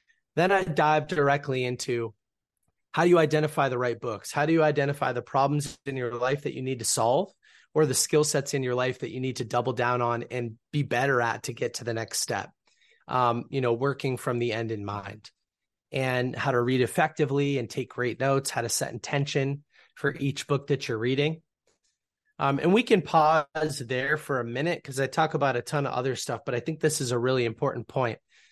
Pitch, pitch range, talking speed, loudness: 135 Hz, 125-145 Hz, 220 wpm, -27 LUFS